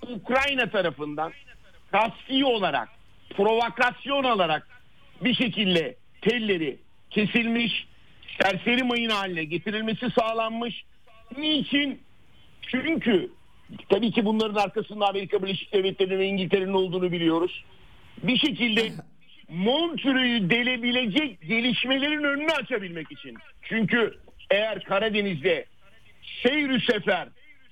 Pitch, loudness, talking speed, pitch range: 225 Hz, -25 LUFS, 90 wpm, 195-250 Hz